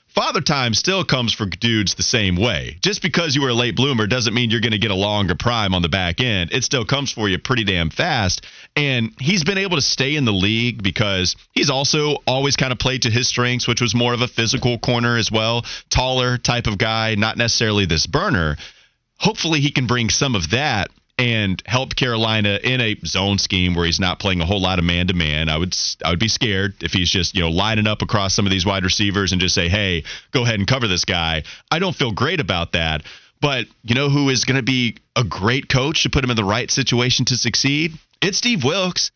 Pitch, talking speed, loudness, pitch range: 115 Hz, 240 wpm, -18 LUFS, 95-130 Hz